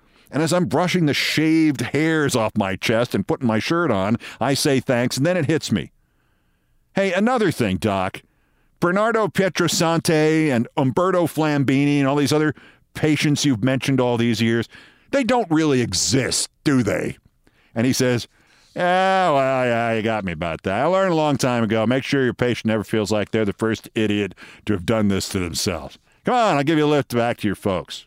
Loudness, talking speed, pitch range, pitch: -20 LUFS, 200 wpm, 110-155 Hz, 130 Hz